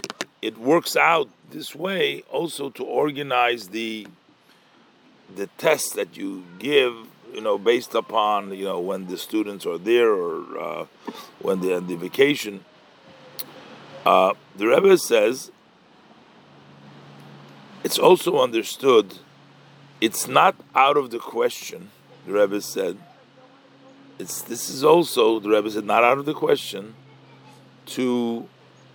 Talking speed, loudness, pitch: 125 wpm, -22 LUFS, 135 Hz